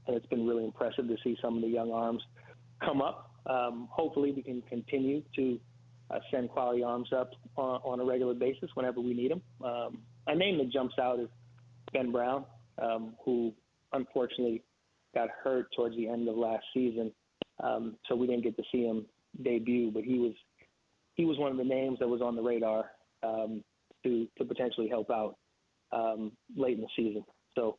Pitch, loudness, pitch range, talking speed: 120 Hz, -34 LUFS, 115-125 Hz, 190 wpm